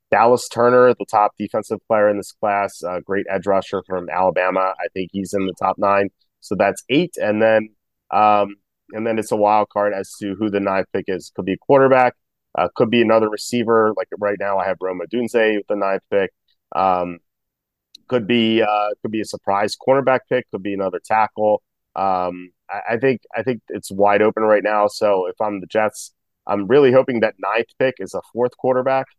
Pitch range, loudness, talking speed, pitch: 100-115 Hz, -19 LUFS, 210 wpm, 105 Hz